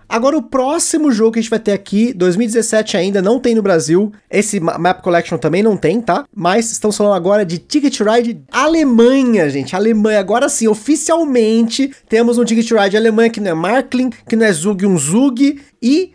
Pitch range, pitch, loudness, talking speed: 200-250 Hz, 225 Hz, -14 LUFS, 195 wpm